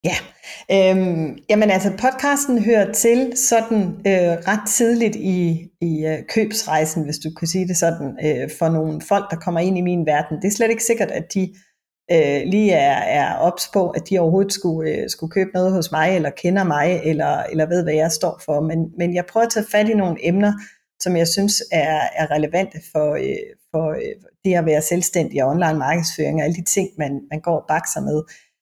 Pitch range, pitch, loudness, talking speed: 160-200 Hz, 180 Hz, -19 LUFS, 210 wpm